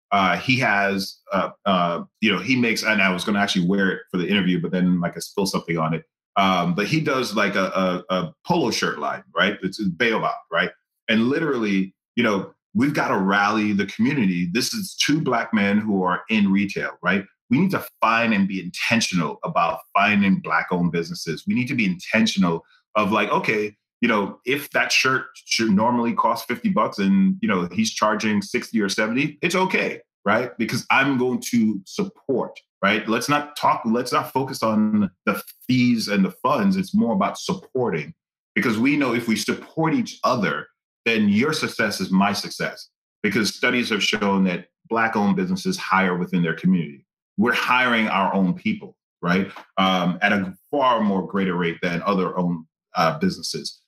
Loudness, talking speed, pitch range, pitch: -21 LUFS, 190 wpm, 95-150 Hz, 105 Hz